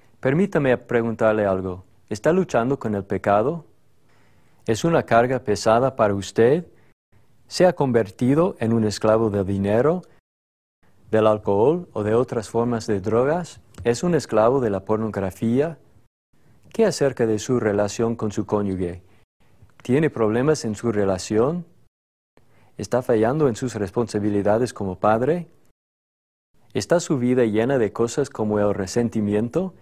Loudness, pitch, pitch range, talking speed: -21 LUFS, 115 Hz, 105-130 Hz, 130 wpm